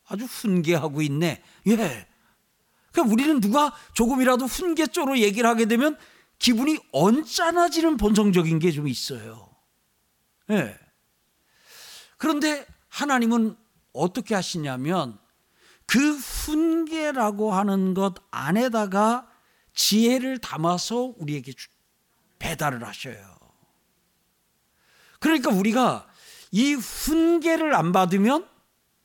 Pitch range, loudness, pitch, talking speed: 185-295 Hz, -23 LUFS, 230 Hz, 220 characters per minute